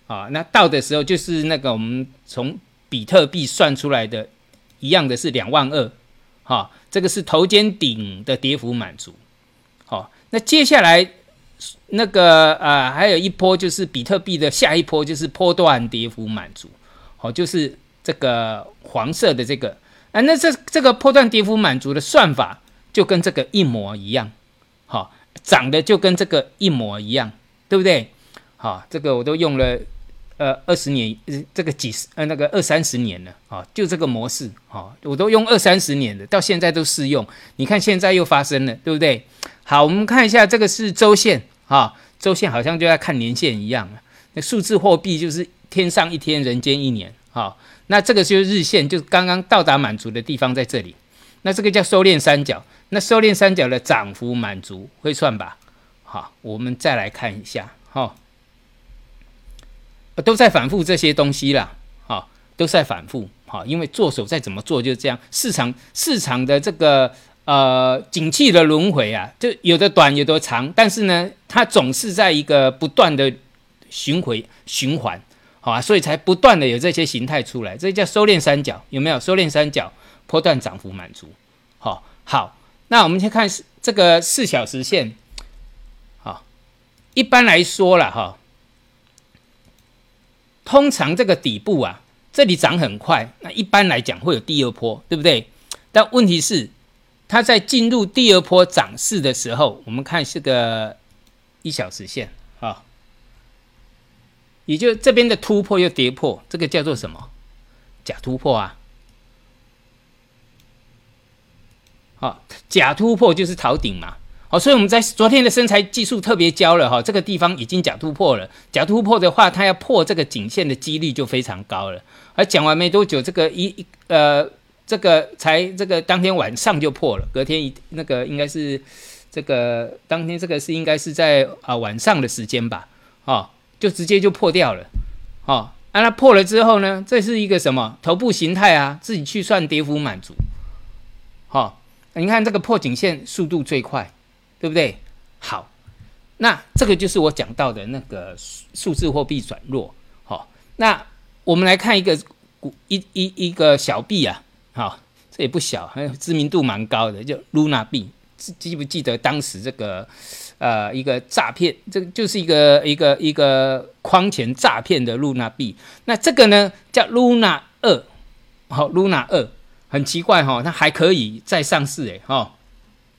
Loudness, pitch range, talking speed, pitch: -17 LUFS, 130-195 Hz, 255 characters per minute, 155 Hz